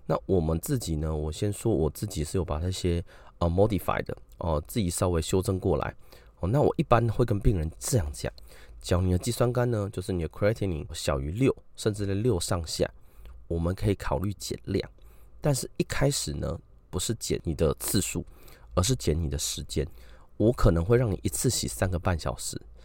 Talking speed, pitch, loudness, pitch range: 315 characters per minute, 90 Hz, -28 LUFS, 80-110 Hz